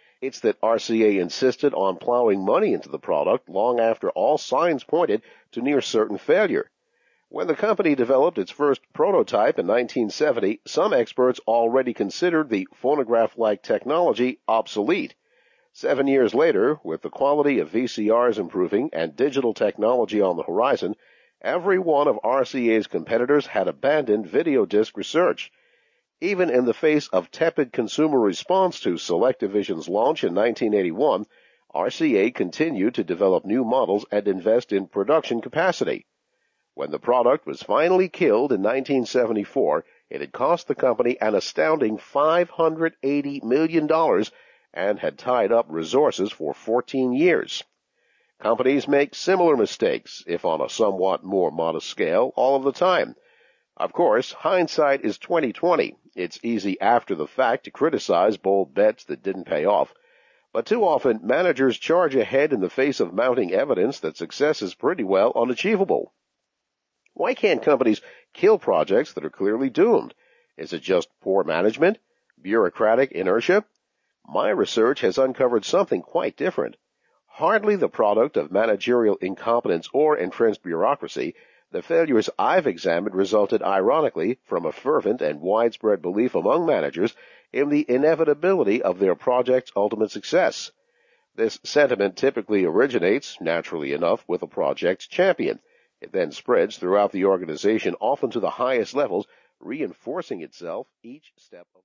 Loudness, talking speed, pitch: -22 LUFS, 145 wpm, 155 Hz